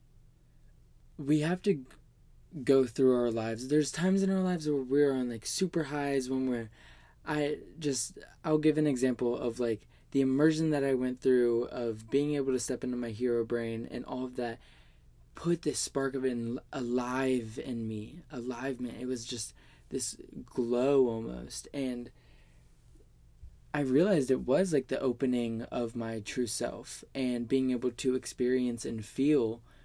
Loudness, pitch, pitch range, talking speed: -31 LUFS, 125 Hz, 115-140 Hz, 165 wpm